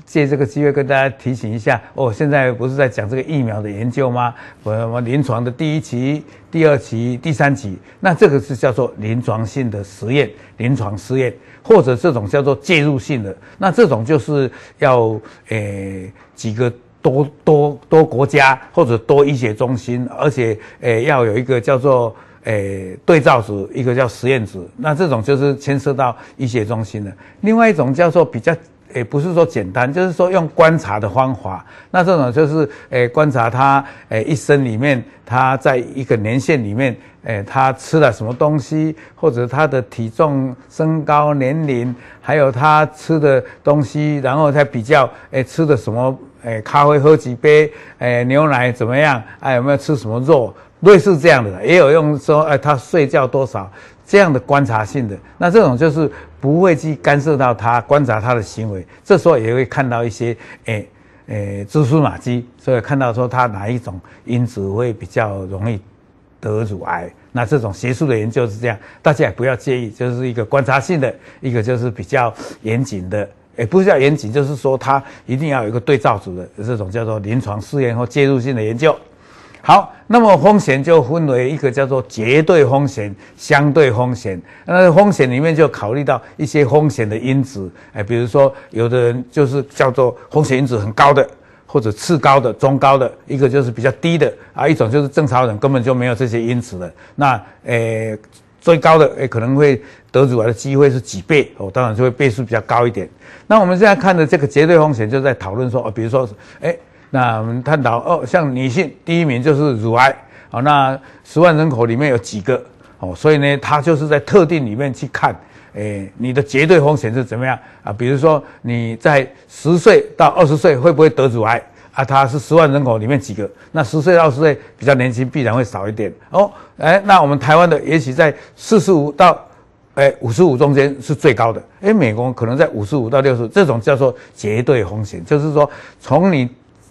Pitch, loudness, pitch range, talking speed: 130 Hz, -15 LUFS, 115-150 Hz, 295 characters per minute